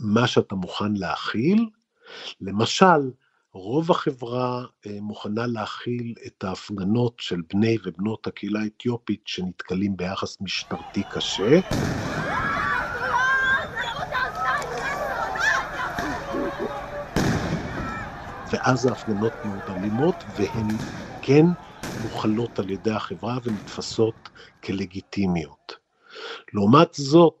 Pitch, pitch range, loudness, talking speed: 115 Hz, 100-130 Hz, -24 LUFS, 70 wpm